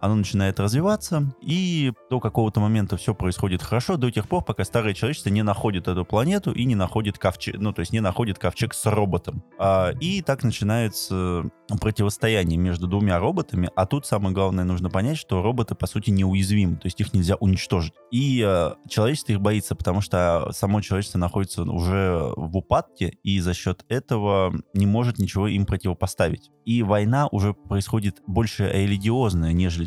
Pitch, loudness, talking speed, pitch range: 100 Hz, -23 LUFS, 165 wpm, 95-115 Hz